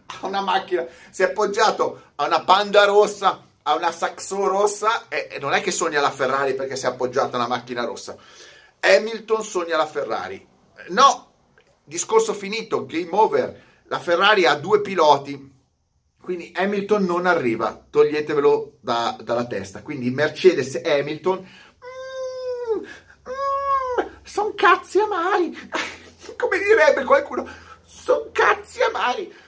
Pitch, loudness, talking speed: 205 Hz, -21 LUFS, 135 wpm